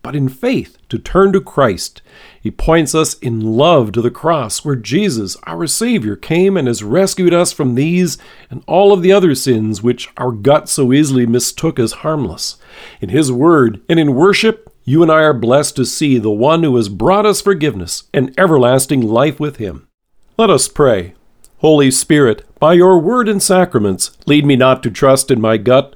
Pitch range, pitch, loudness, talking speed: 120-170 Hz, 145 Hz, -12 LUFS, 190 wpm